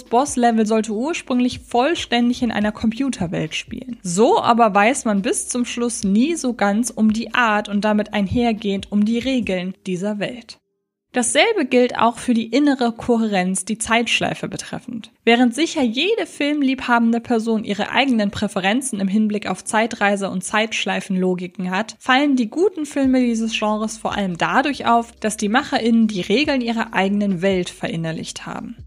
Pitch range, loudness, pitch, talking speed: 205-245 Hz, -19 LUFS, 225 Hz, 155 wpm